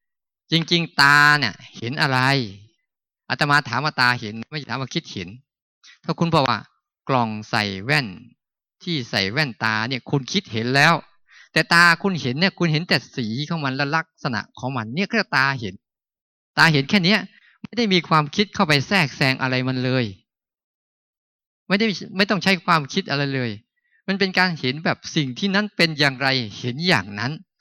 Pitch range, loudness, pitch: 125-175 Hz, -20 LUFS, 145 Hz